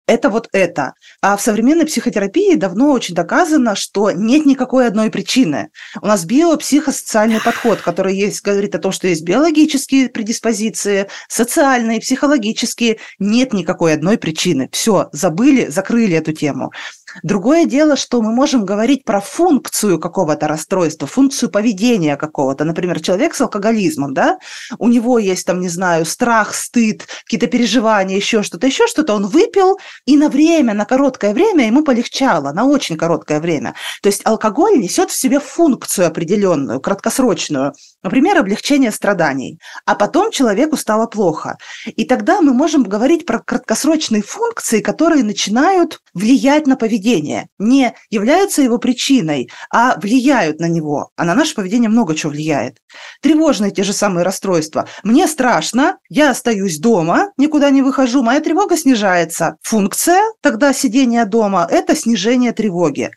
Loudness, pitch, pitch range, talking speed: -14 LUFS, 235 Hz, 195-275 Hz, 145 wpm